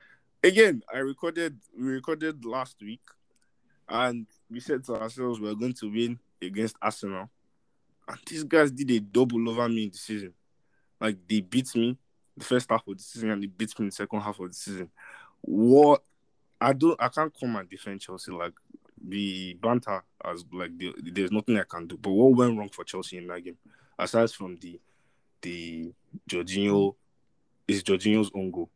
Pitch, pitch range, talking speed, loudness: 110 Hz, 100-125 Hz, 190 wpm, -27 LUFS